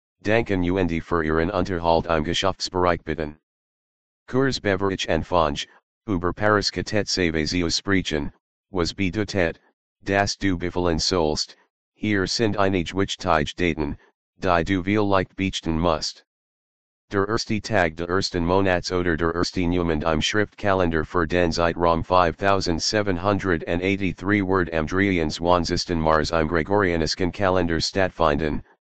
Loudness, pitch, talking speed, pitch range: -23 LUFS, 90 Hz, 120 wpm, 80-95 Hz